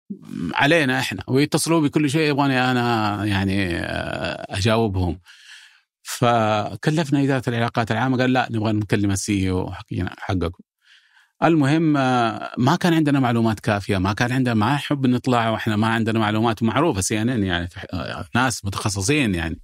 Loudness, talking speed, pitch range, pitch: -21 LUFS, 135 wpm, 105-140 Hz, 115 Hz